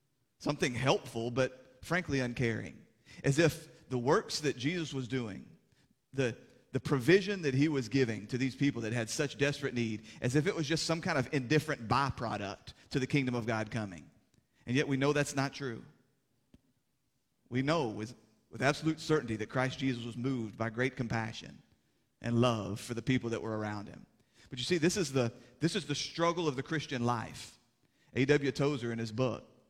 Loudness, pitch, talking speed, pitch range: -33 LUFS, 130 Hz, 190 wpm, 115-145 Hz